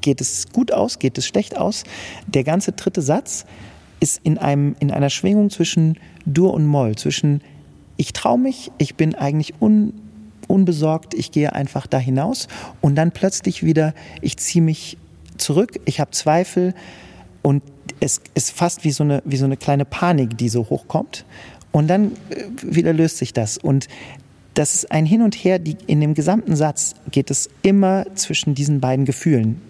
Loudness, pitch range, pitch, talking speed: -19 LUFS, 135-180 Hz, 155 Hz, 175 wpm